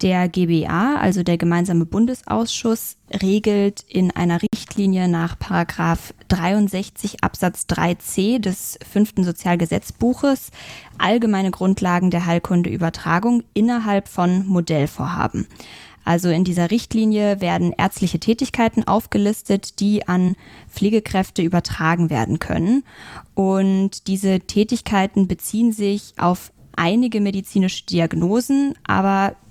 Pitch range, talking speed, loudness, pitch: 175-210 Hz, 100 wpm, -20 LUFS, 195 Hz